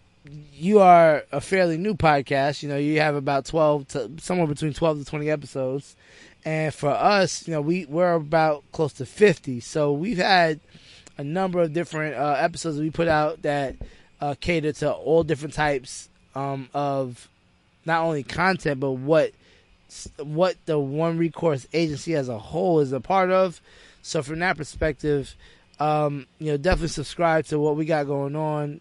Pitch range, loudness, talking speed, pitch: 140-165 Hz, -23 LUFS, 175 wpm, 150 Hz